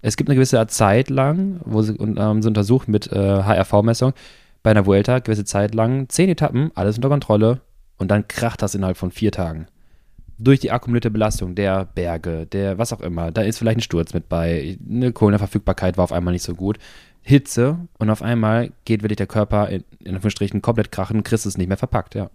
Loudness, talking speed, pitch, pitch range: -19 LUFS, 210 wpm, 110 Hz, 95-120 Hz